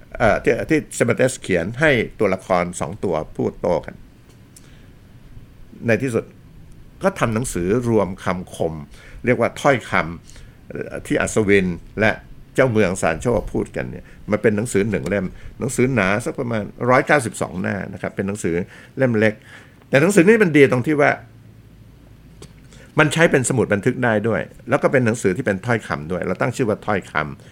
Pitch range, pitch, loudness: 100-130 Hz, 115 Hz, -19 LUFS